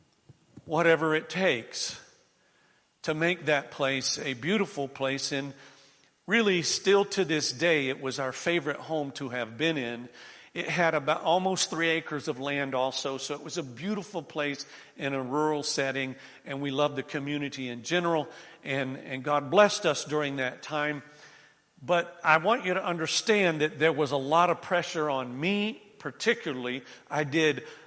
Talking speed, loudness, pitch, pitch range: 165 wpm, -28 LUFS, 150 Hz, 135-170 Hz